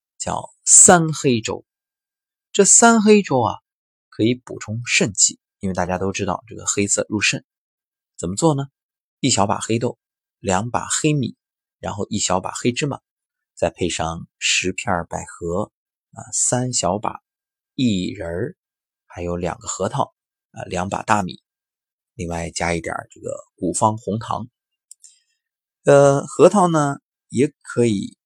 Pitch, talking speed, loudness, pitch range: 110 Hz, 195 characters per minute, -18 LUFS, 90-145 Hz